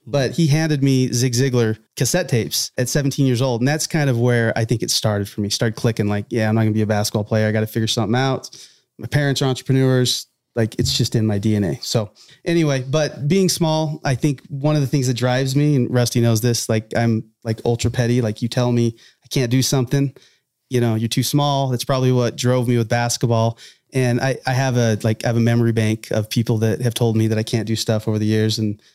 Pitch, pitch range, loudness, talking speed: 120 Hz, 115-135 Hz, -19 LUFS, 250 wpm